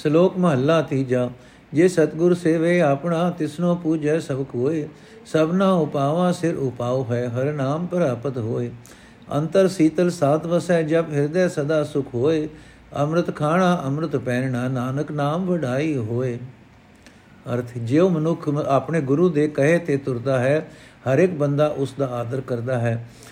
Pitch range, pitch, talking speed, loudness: 130-165 Hz, 150 Hz, 145 wpm, -21 LUFS